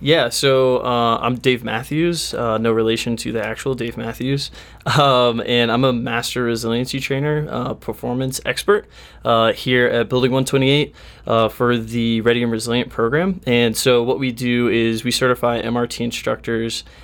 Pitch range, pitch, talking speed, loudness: 115-130 Hz, 120 Hz, 160 wpm, -18 LUFS